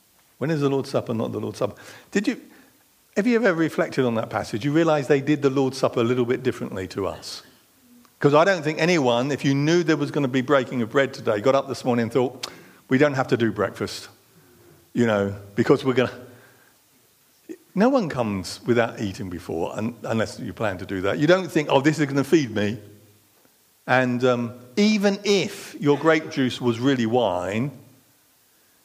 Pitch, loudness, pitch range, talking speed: 135 Hz, -23 LUFS, 120-160 Hz, 205 wpm